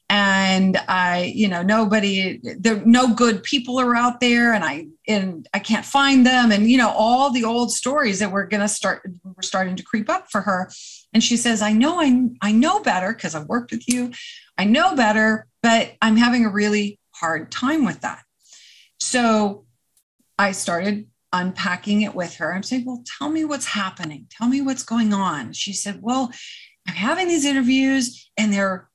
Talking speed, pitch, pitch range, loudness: 190 wpm, 220 Hz, 195-250 Hz, -19 LUFS